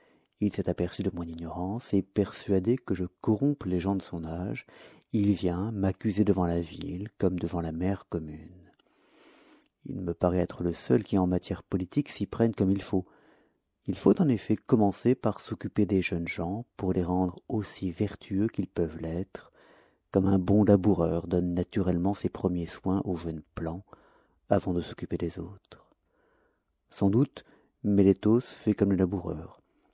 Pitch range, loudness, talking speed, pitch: 90-105 Hz, -29 LUFS, 170 wpm, 95 Hz